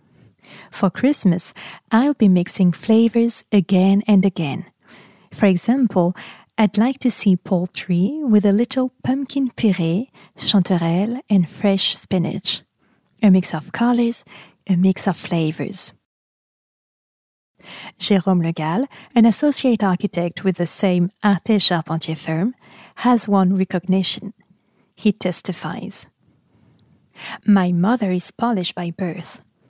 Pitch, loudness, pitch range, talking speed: 195 Hz, -19 LUFS, 180-225 Hz, 115 wpm